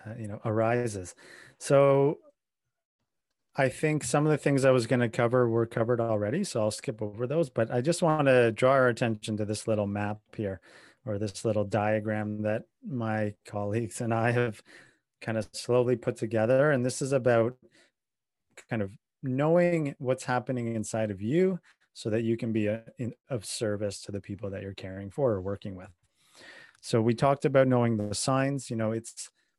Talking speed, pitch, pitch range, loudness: 190 wpm, 115 Hz, 105-130 Hz, -28 LUFS